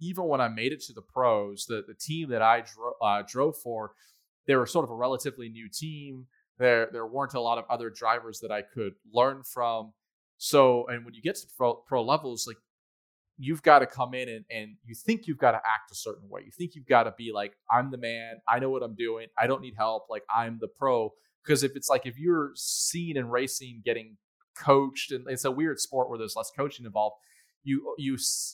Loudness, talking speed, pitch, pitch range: -28 LUFS, 230 wpm, 125 Hz, 115-140 Hz